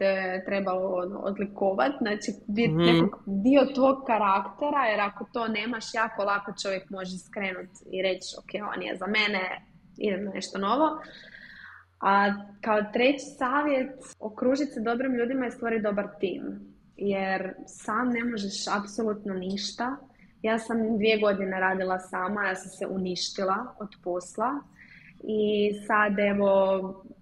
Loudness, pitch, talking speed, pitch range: -27 LUFS, 205 Hz, 130 wpm, 190-235 Hz